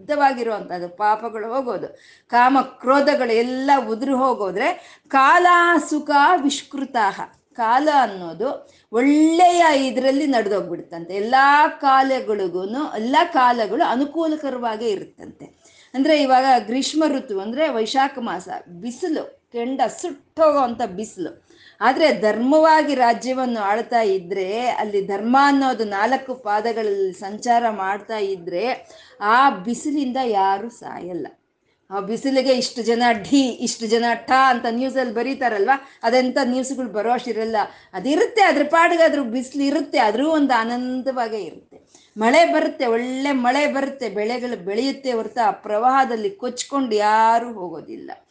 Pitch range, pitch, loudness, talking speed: 225-285 Hz, 255 Hz, -19 LUFS, 110 wpm